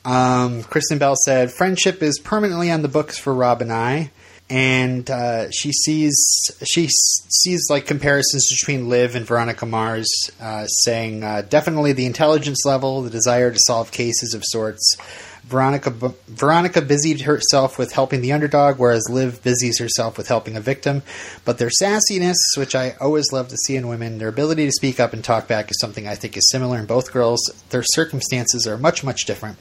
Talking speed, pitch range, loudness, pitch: 190 wpm, 115-145 Hz, -18 LUFS, 130 Hz